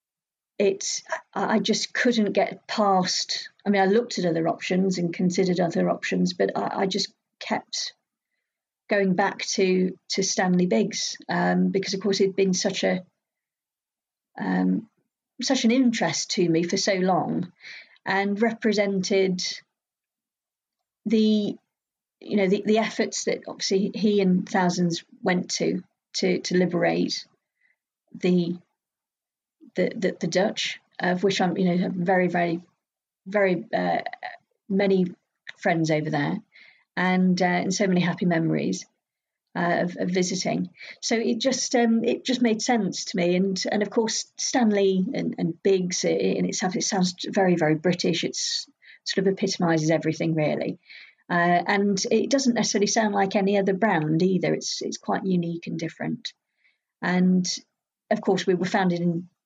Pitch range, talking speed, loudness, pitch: 180-215 Hz, 150 wpm, -24 LUFS, 195 Hz